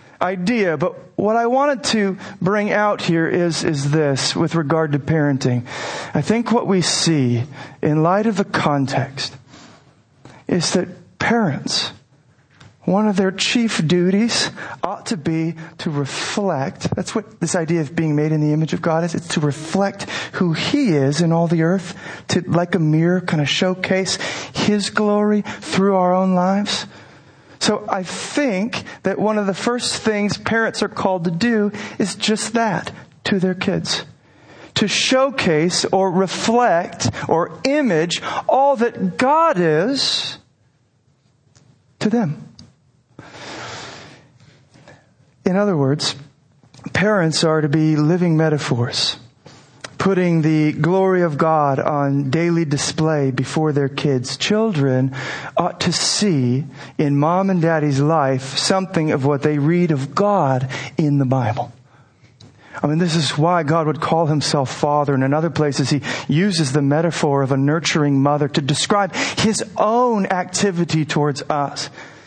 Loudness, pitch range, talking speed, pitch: -18 LUFS, 145-195 Hz, 145 wpm, 165 Hz